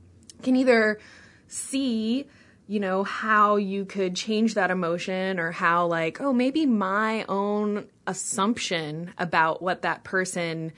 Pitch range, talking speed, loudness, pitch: 175-220 Hz, 130 wpm, -25 LUFS, 195 Hz